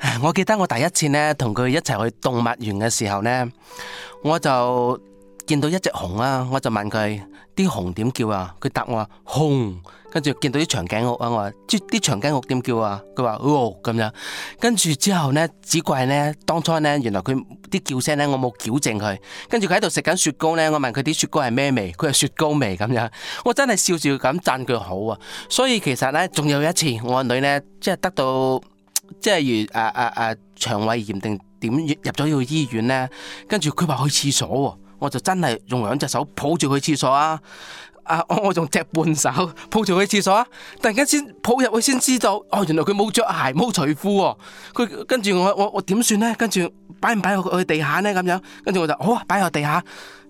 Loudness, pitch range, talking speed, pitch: -21 LUFS, 125-185 Hz, 295 characters per minute, 150 Hz